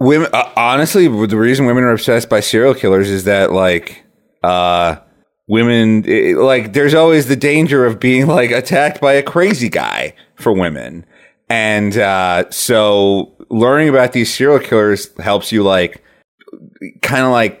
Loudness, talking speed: -12 LUFS, 155 wpm